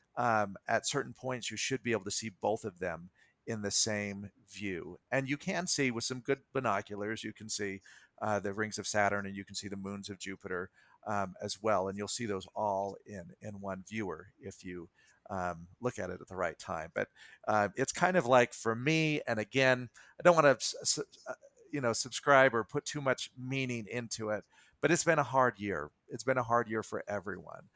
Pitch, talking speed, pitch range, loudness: 110 Hz, 215 wpm, 100-130 Hz, -33 LUFS